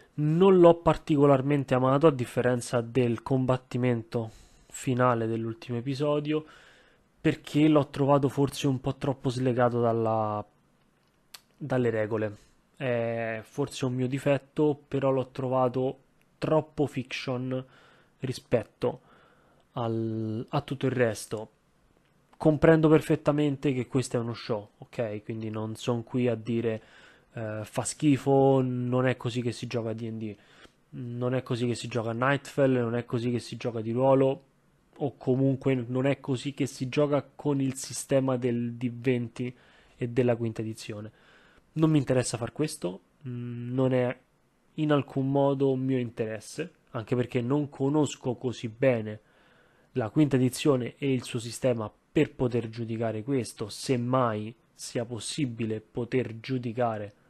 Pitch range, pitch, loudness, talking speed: 120-140 Hz, 130 Hz, -28 LUFS, 135 wpm